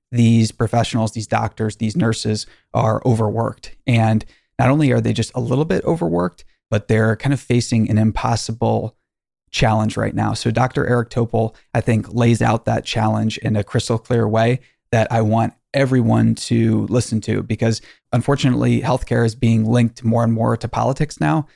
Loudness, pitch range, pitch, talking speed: -18 LUFS, 110-120 Hz, 115 Hz, 175 wpm